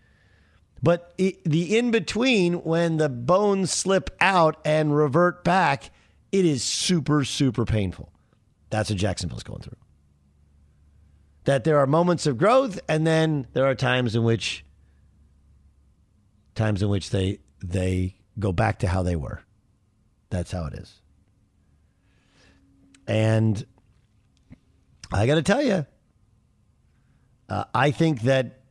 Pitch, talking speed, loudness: 110 Hz, 130 wpm, -23 LUFS